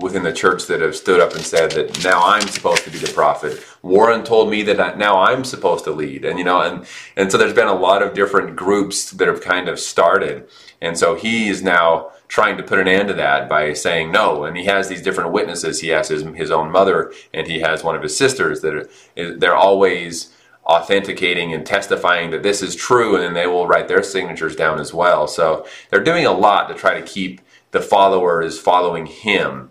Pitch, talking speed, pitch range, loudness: 100 Hz, 225 wpm, 85-115 Hz, -16 LUFS